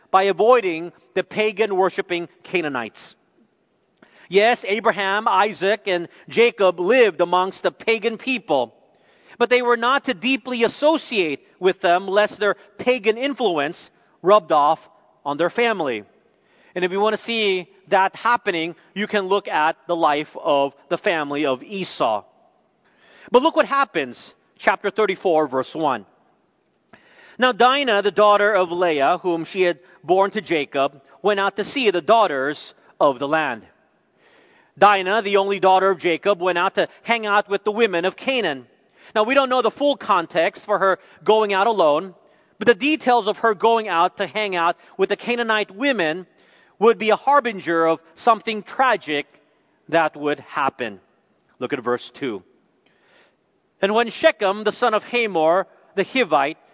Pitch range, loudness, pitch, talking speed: 175-225 Hz, -20 LUFS, 200 Hz, 155 wpm